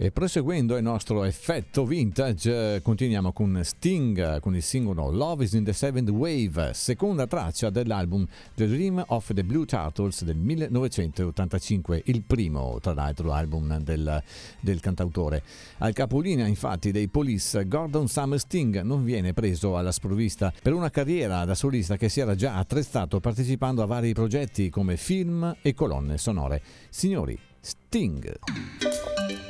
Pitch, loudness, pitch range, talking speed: 110 Hz, -27 LUFS, 95-130 Hz, 145 wpm